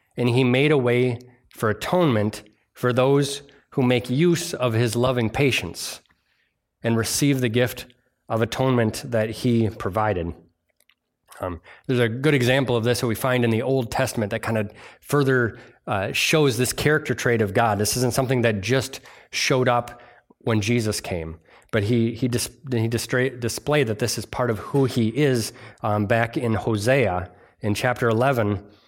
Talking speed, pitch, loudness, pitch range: 170 wpm, 120 Hz, -22 LUFS, 110-130 Hz